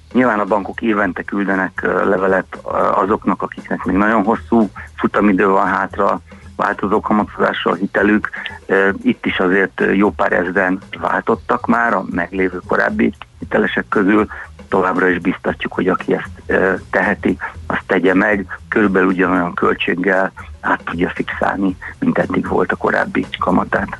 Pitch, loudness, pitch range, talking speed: 95 Hz, -16 LUFS, 90-100 Hz, 130 wpm